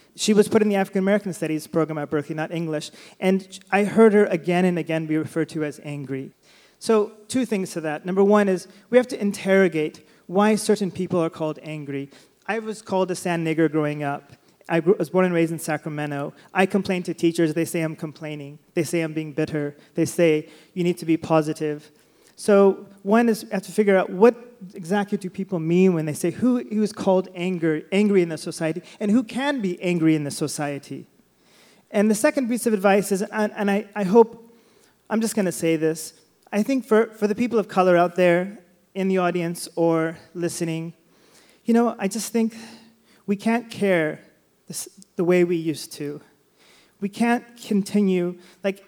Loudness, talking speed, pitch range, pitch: -22 LUFS, 200 wpm, 160-205 Hz, 180 Hz